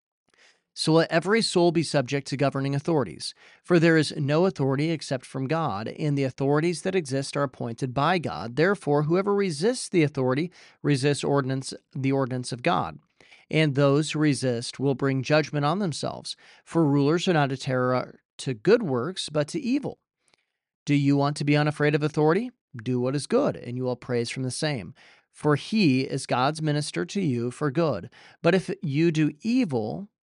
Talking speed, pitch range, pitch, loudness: 180 wpm, 135-165 Hz, 150 Hz, -25 LUFS